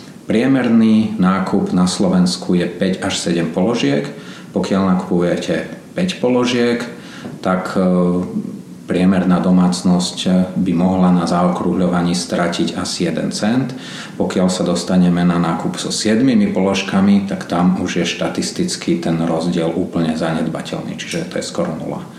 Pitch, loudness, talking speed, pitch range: 90 Hz, -17 LUFS, 125 wpm, 90-105 Hz